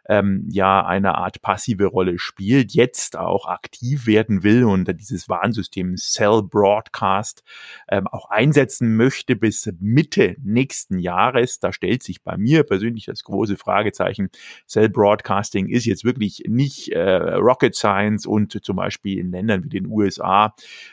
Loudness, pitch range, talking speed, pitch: -19 LUFS, 95-115 Hz, 140 wpm, 105 Hz